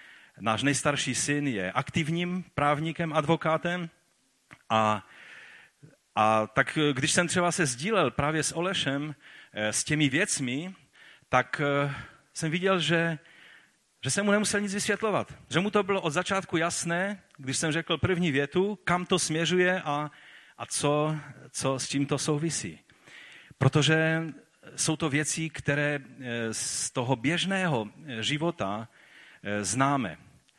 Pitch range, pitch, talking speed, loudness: 135-170 Hz, 150 Hz, 125 wpm, -28 LUFS